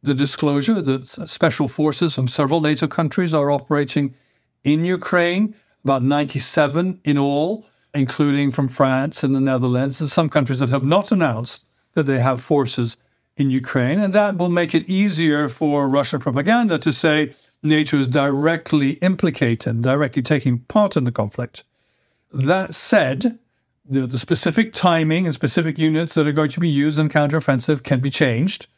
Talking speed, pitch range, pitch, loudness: 160 wpm, 135-165 Hz, 150 Hz, -19 LUFS